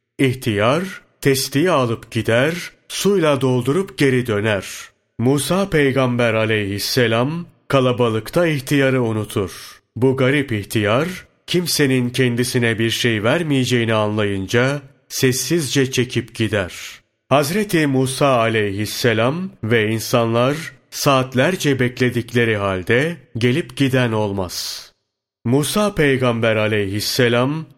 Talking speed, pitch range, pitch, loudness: 85 wpm, 115-140 Hz, 125 Hz, -18 LUFS